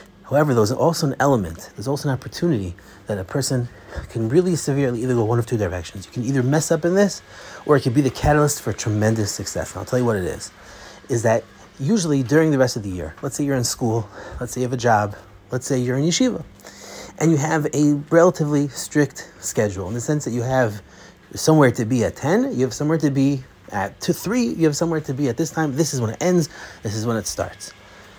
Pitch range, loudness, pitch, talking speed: 115-155 Hz, -21 LUFS, 135 Hz, 240 wpm